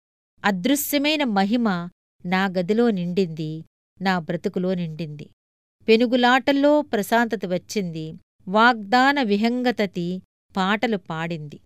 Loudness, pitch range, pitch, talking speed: -22 LUFS, 175-245 Hz, 205 Hz, 75 wpm